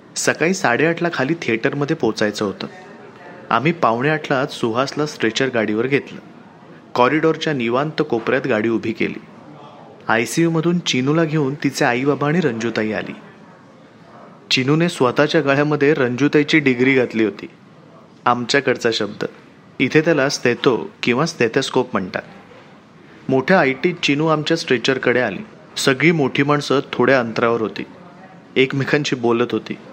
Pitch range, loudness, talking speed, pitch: 115-150 Hz, -18 LUFS, 120 wpm, 135 Hz